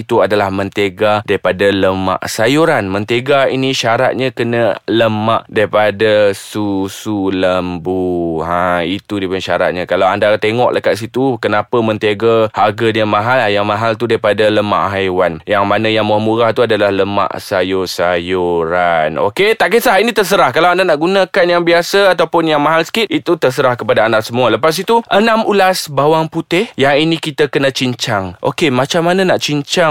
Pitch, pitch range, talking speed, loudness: 110 Hz, 100-150 Hz, 160 wpm, -13 LUFS